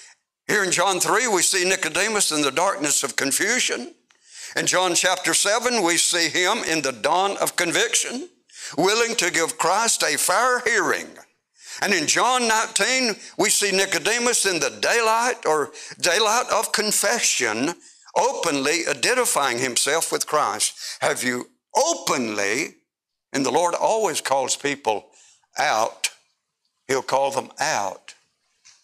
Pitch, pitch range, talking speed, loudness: 195 Hz, 160-230 Hz, 135 wpm, -20 LUFS